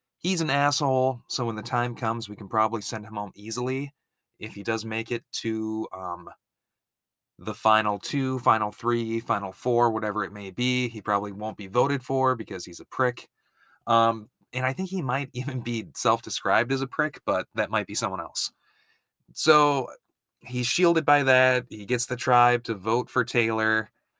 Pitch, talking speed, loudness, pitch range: 120 Hz, 185 wpm, -26 LUFS, 110-130 Hz